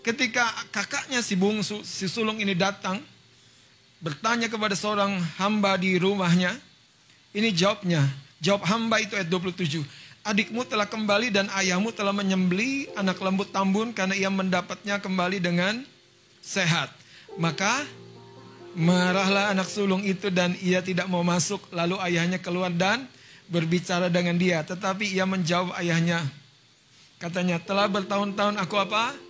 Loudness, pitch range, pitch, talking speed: -25 LUFS, 175-205 Hz, 190 Hz, 130 wpm